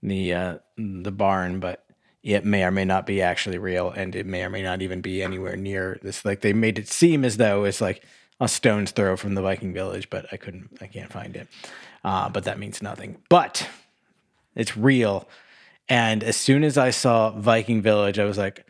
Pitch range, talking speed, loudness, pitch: 95-110 Hz, 210 wpm, -23 LUFS, 100 Hz